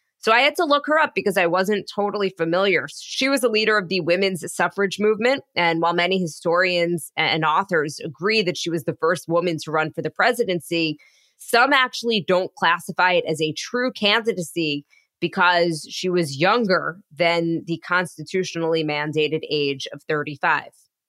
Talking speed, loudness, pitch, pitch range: 170 wpm, -21 LUFS, 175 Hz, 165-205 Hz